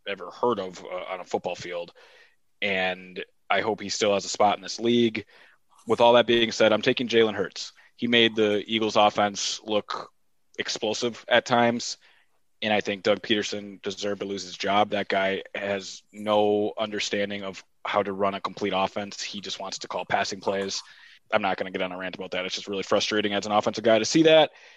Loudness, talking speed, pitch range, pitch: -25 LUFS, 210 wpm, 100-115 Hz, 105 Hz